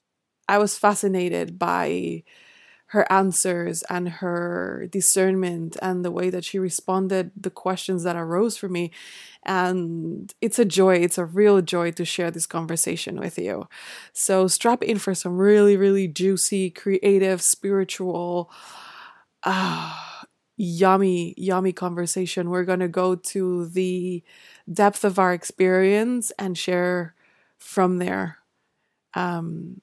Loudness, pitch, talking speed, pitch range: -22 LUFS, 185 Hz, 130 wpm, 180-195 Hz